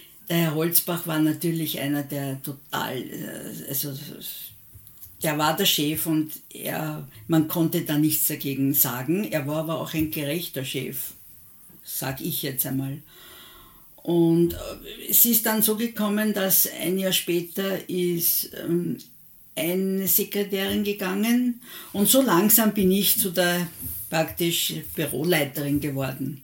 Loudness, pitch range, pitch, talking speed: -23 LUFS, 145-190 Hz, 165 Hz, 125 wpm